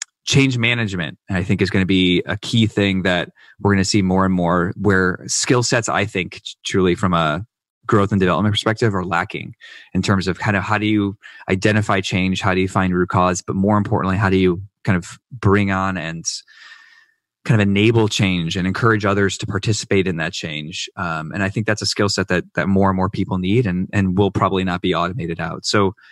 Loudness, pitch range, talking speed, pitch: -18 LUFS, 95-105 Hz, 220 wpm, 100 Hz